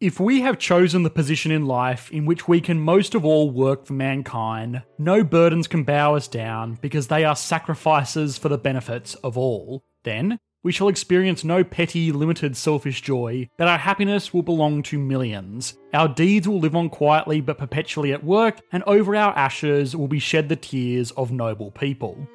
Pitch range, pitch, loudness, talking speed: 135-170 Hz, 150 Hz, -21 LUFS, 190 wpm